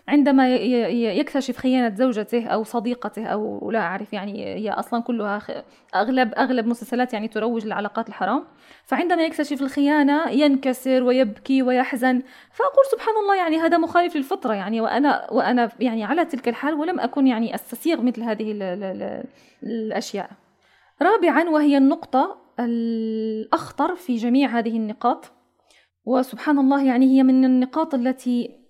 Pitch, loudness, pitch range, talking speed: 255 Hz, -21 LUFS, 230-285 Hz, 130 wpm